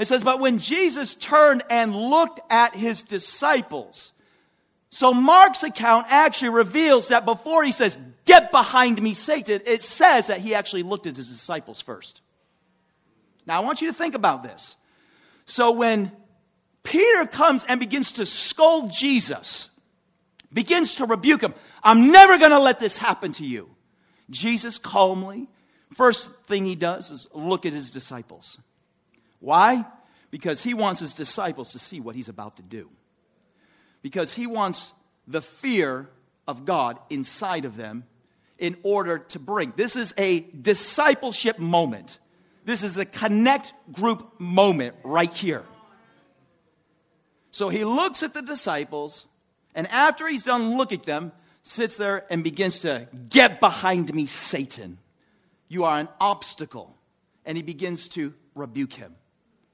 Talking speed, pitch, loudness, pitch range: 145 wpm, 210 Hz, -20 LUFS, 165-255 Hz